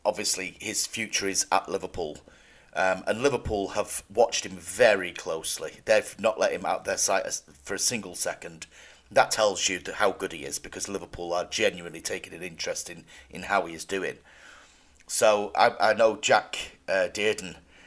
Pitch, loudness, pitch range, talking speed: 95 Hz, -27 LUFS, 90-105 Hz, 180 wpm